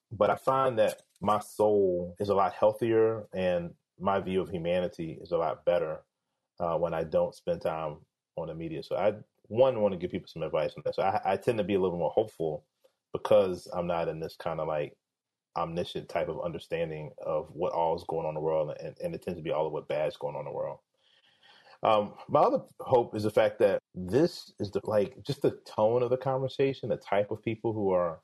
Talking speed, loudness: 235 wpm, -30 LUFS